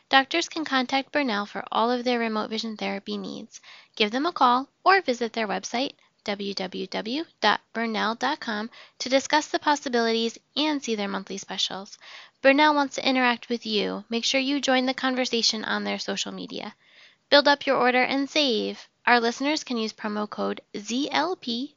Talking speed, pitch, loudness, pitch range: 165 wpm, 245 Hz, -25 LUFS, 215-275 Hz